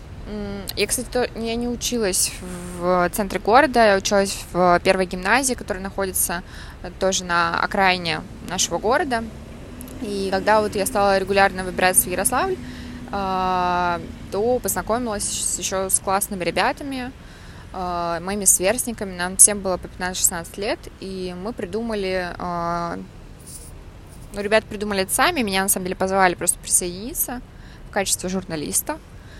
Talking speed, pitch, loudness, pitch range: 120 wpm, 190 Hz, -21 LUFS, 180-215 Hz